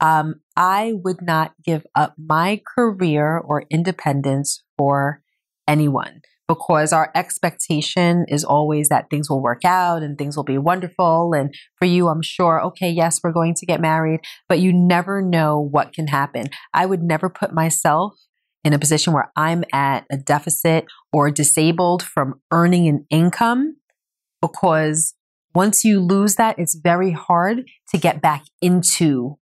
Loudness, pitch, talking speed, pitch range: -18 LUFS, 165 Hz, 155 wpm, 150-180 Hz